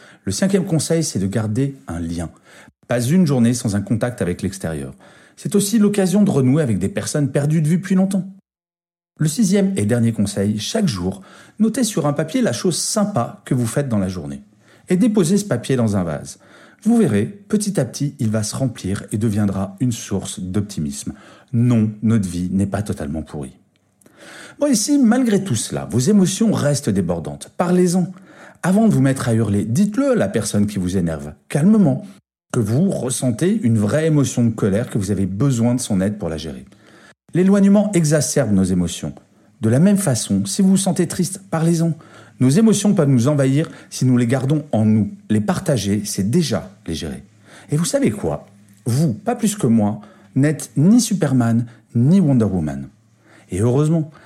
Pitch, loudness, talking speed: 130 Hz, -18 LUFS, 185 wpm